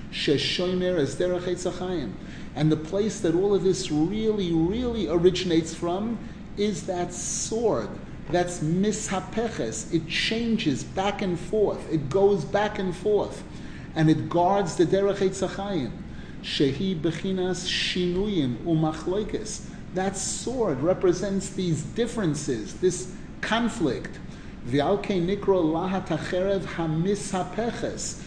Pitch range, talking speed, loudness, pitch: 165-200 Hz, 100 wpm, -26 LUFS, 185 Hz